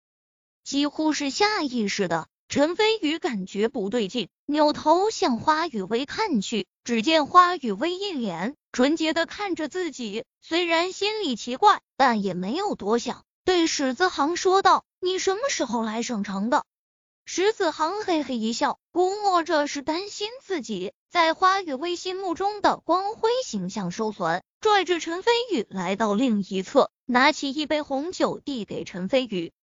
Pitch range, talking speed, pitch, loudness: 230-360 Hz, 230 characters per minute, 300 Hz, -24 LUFS